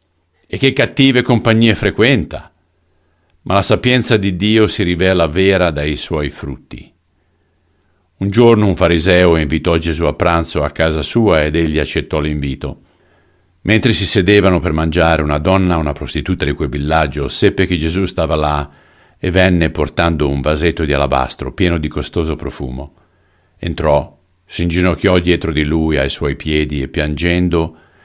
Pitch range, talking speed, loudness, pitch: 75-95 Hz, 150 wpm, -14 LUFS, 85 Hz